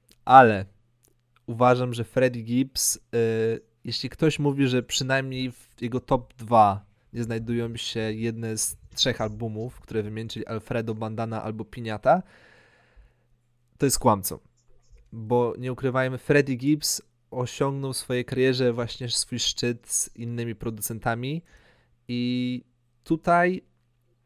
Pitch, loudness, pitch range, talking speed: 120 Hz, -25 LUFS, 115-130 Hz, 115 wpm